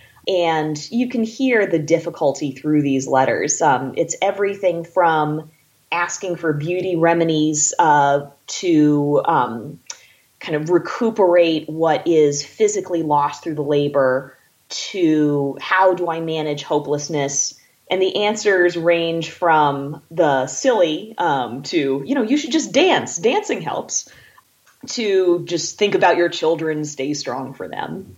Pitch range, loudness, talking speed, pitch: 145-185 Hz, -19 LUFS, 135 wpm, 165 Hz